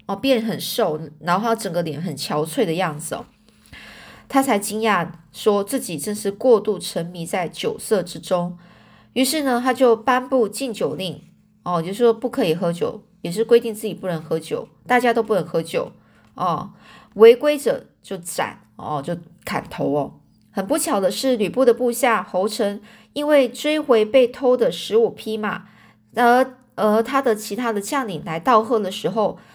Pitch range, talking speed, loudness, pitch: 180-245 Hz, 245 characters per minute, -20 LUFS, 215 Hz